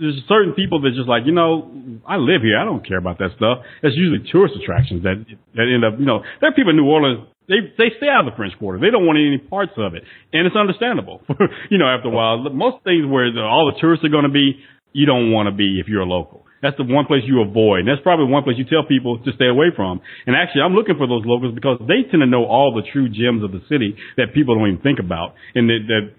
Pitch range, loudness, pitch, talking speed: 115-160 Hz, -17 LUFS, 135 Hz, 280 wpm